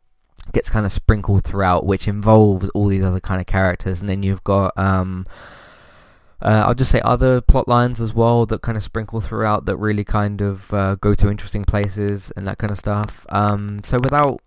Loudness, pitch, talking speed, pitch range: -19 LUFS, 105 Hz, 205 wpm, 95-110 Hz